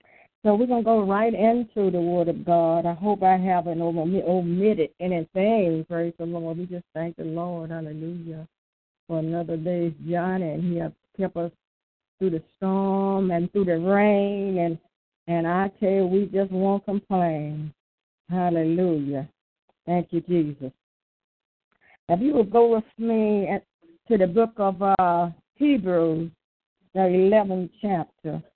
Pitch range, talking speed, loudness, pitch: 170-200 Hz, 150 wpm, -24 LUFS, 180 Hz